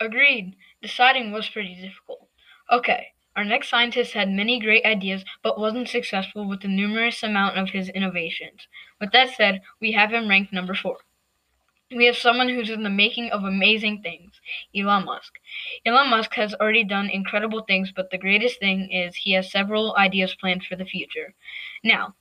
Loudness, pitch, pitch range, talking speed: -21 LUFS, 210 Hz, 195-230 Hz, 175 wpm